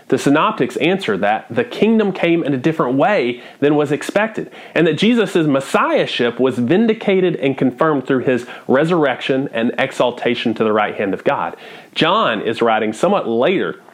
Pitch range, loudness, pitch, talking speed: 130-170 Hz, -16 LUFS, 145 Hz, 165 wpm